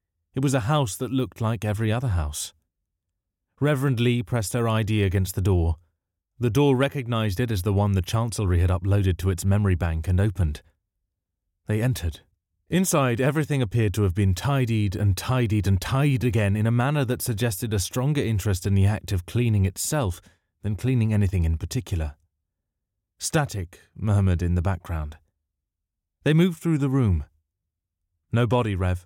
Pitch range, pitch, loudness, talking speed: 90-120 Hz, 100 Hz, -24 LUFS, 165 wpm